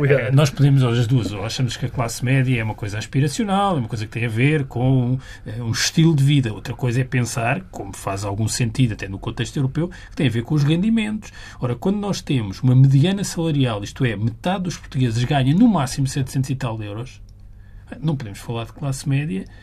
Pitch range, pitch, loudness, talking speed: 115-145 Hz, 130 Hz, -20 LUFS, 220 wpm